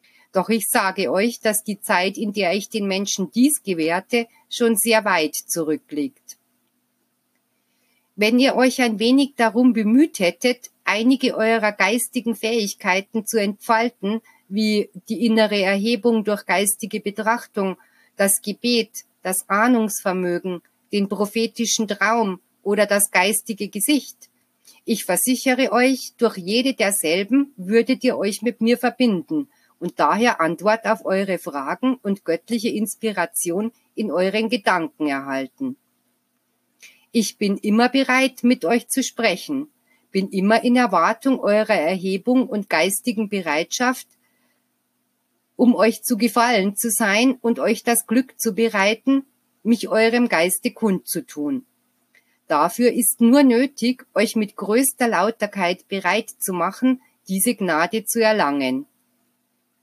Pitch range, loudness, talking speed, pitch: 195-240 Hz, -20 LUFS, 125 wpm, 220 Hz